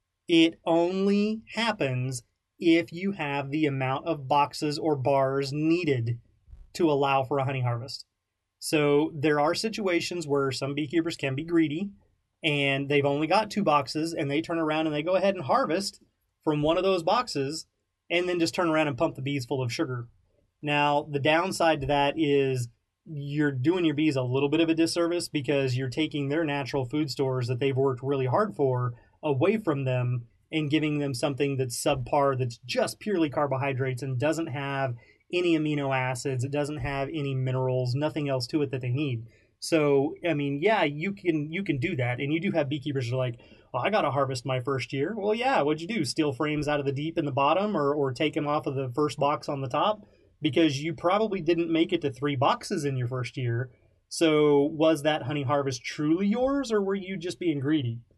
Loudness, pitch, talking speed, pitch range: -27 LUFS, 145 Hz, 205 wpm, 135-160 Hz